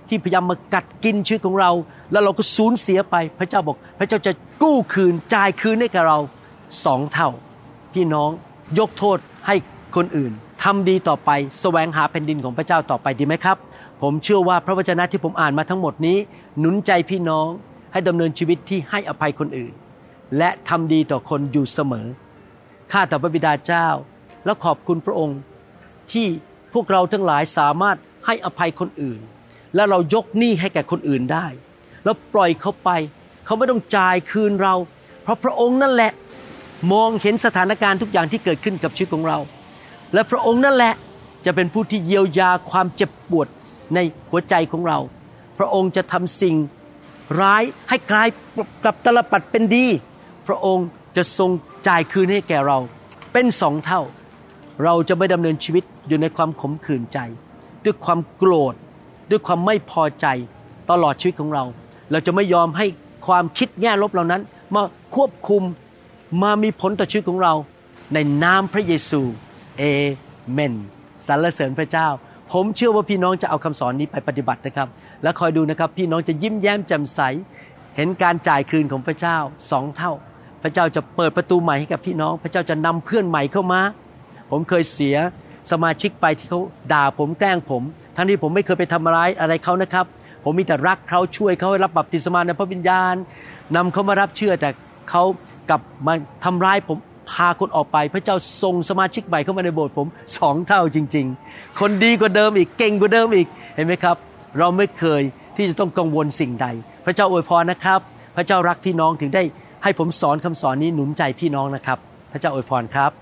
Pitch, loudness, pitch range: 175 Hz, -19 LUFS, 150-195 Hz